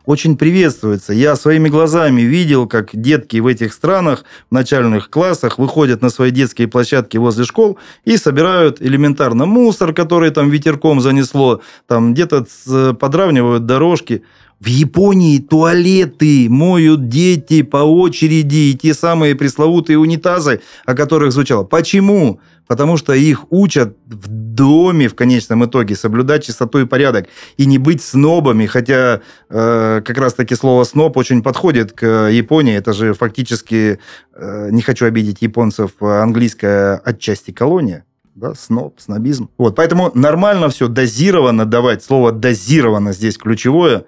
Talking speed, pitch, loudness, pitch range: 135 wpm, 135 Hz, -12 LUFS, 115-155 Hz